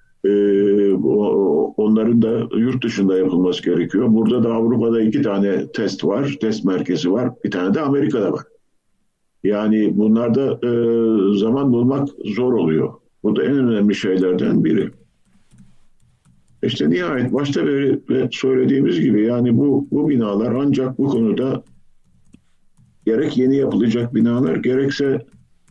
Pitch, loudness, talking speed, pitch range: 115 Hz, -18 LUFS, 115 wpm, 105-130 Hz